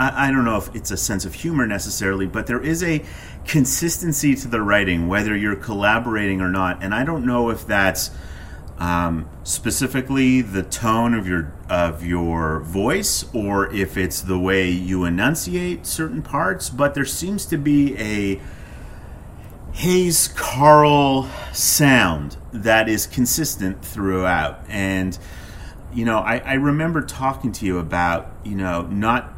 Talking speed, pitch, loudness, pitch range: 150 wpm, 100 Hz, -20 LUFS, 90-130 Hz